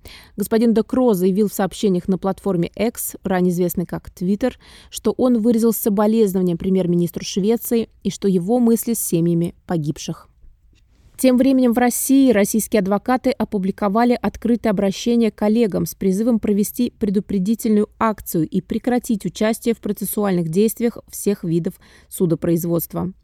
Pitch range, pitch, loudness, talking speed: 190-230 Hz, 210 Hz, -19 LUFS, 125 wpm